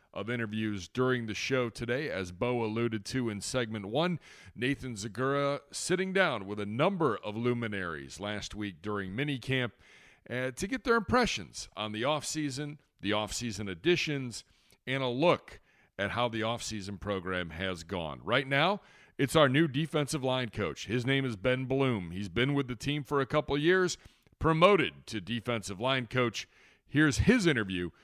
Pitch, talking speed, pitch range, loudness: 125 Hz, 165 wpm, 105-140 Hz, -31 LUFS